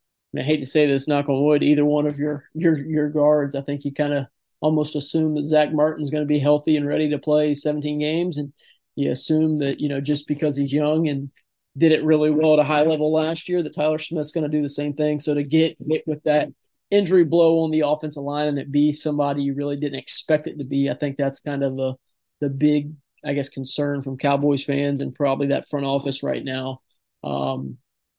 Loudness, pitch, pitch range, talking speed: -22 LUFS, 150 Hz, 140-155 Hz, 235 wpm